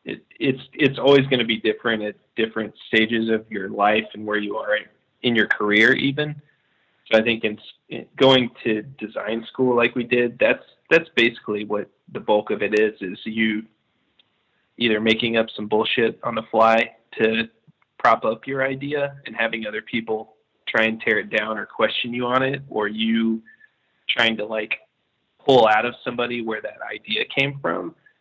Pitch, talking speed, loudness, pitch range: 115 Hz, 185 wpm, -21 LUFS, 110-125 Hz